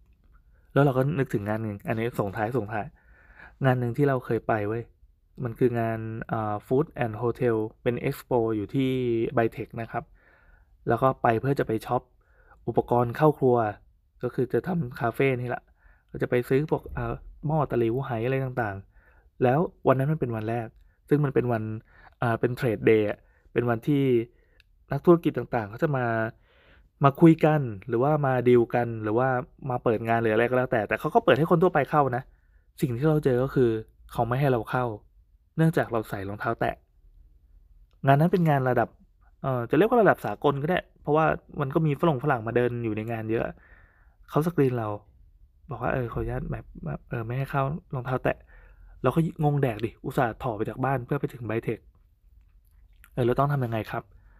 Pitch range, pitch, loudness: 110-135 Hz, 120 Hz, -26 LUFS